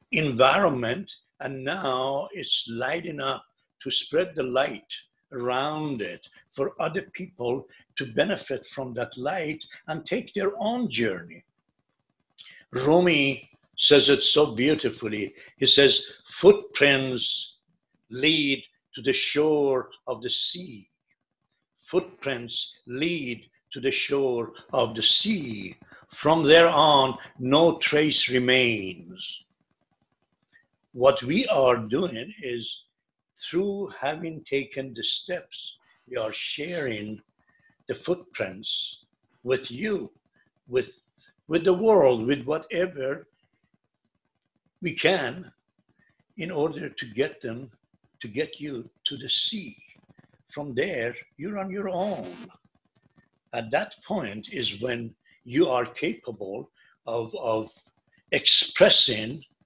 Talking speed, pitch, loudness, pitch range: 110 wpm, 145 Hz, -24 LUFS, 130-175 Hz